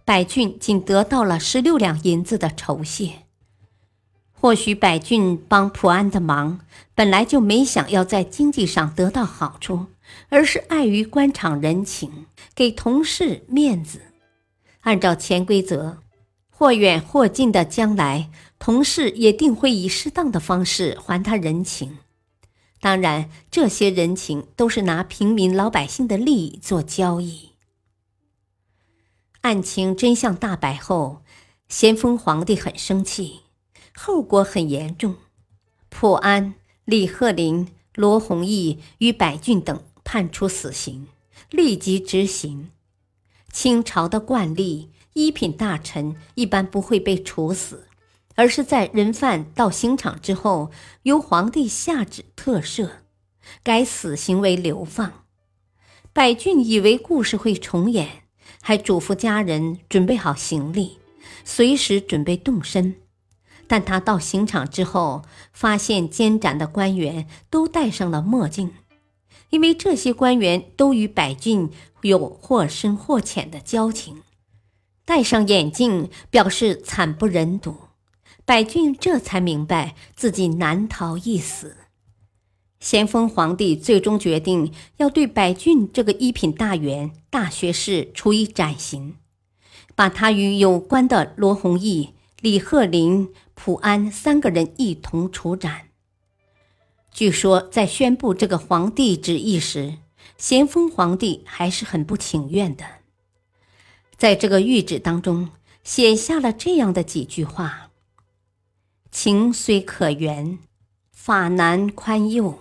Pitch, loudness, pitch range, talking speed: 185 Hz, -20 LUFS, 150-220 Hz, 190 characters per minute